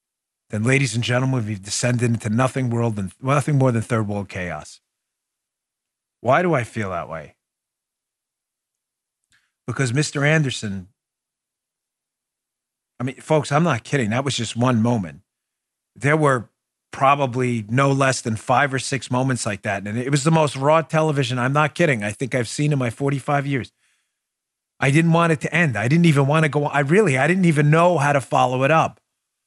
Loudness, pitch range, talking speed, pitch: -20 LUFS, 115-150 Hz, 185 wpm, 130 Hz